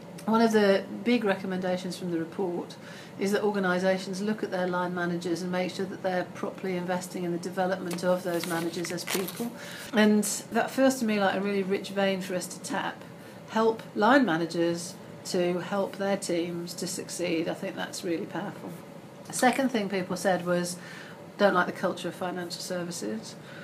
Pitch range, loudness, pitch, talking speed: 180-200 Hz, -28 LUFS, 185 Hz, 185 wpm